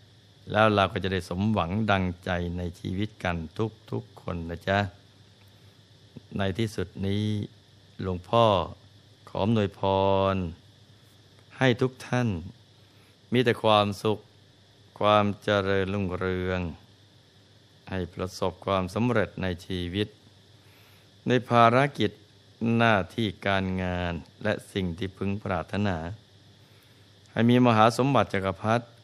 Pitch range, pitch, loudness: 95-110 Hz, 100 Hz, -27 LUFS